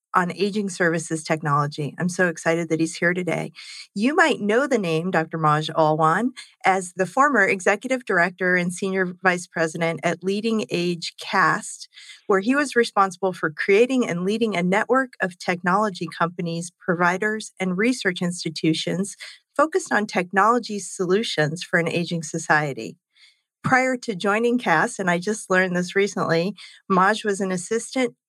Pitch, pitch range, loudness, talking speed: 185 Hz, 170-215 Hz, -22 LUFS, 150 wpm